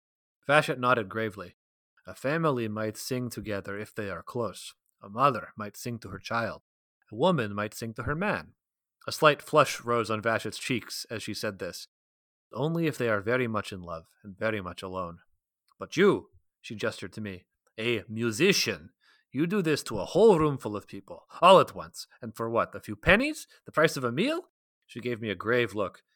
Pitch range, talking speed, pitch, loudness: 100-125 Hz, 200 wpm, 110 Hz, -28 LUFS